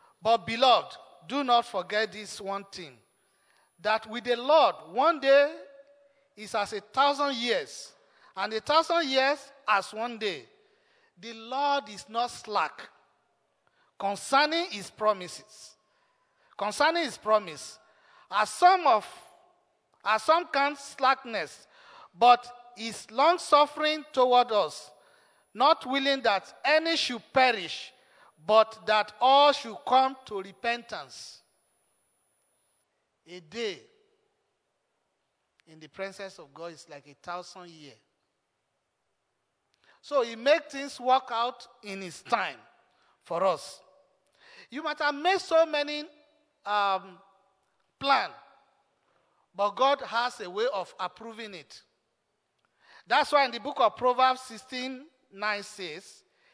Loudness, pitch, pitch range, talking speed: -27 LUFS, 255 Hz, 210-295 Hz, 120 wpm